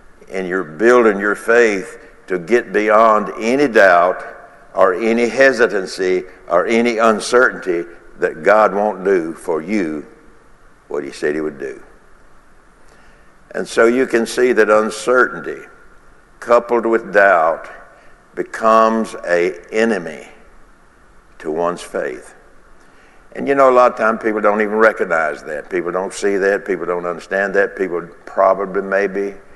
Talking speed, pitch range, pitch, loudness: 135 wpm, 100-120 Hz, 110 Hz, -16 LUFS